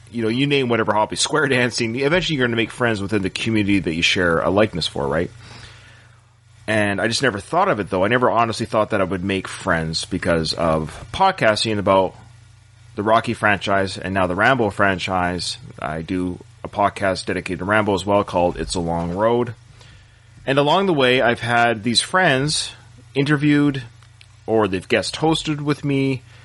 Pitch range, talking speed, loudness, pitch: 95-120 Hz, 185 wpm, -19 LUFS, 110 Hz